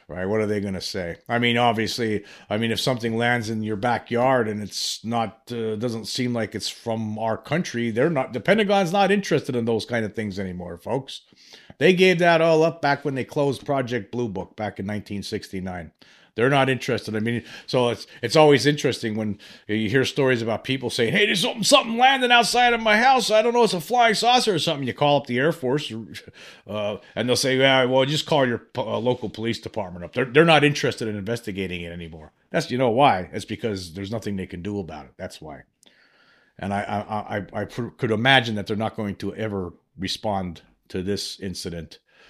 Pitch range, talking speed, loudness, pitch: 105-140 Hz, 215 wpm, -22 LUFS, 115 Hz